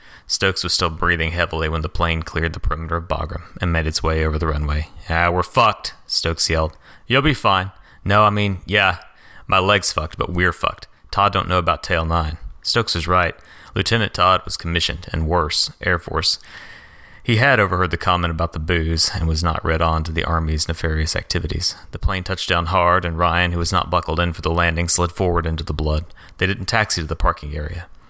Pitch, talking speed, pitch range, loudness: 85 Hz, 215 wpm, 80-90 Hz, -19 LUFS